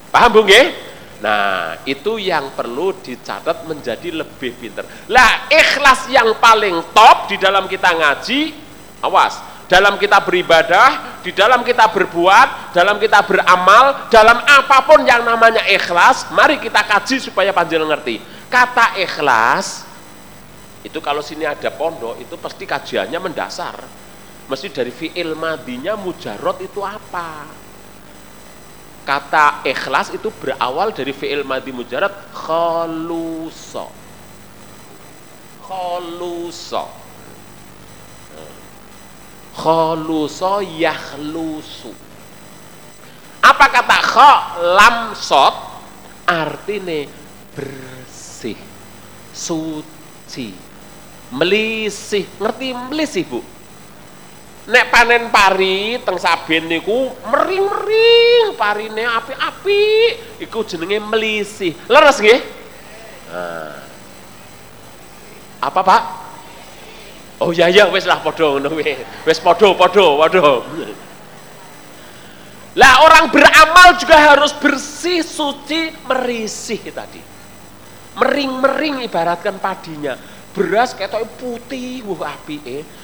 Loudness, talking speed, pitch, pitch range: -13 LUFS, 90 wpm, 200 Hz, 165-260 Hz